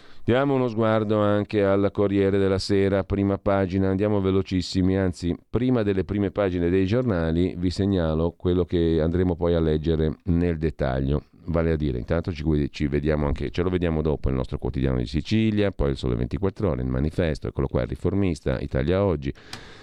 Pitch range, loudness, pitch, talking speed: 75-100 Hz, -24 LUFS, 90 Hz, 175 wpm